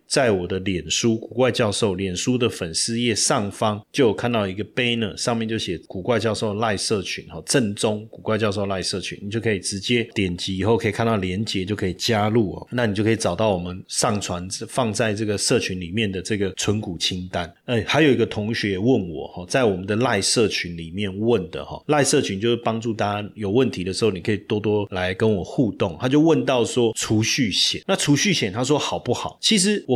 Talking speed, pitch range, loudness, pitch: 330 characters per minute, 95-115 Hz, -22 LUFS, 105 Hz